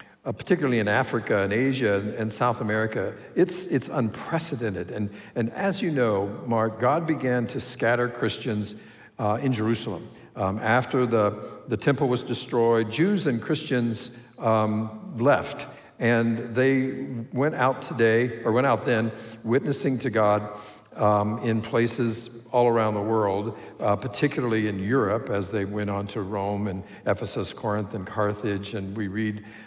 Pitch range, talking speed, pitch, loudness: 105-125 Hz, 150 wpm, 115 Hz, -25 LUFS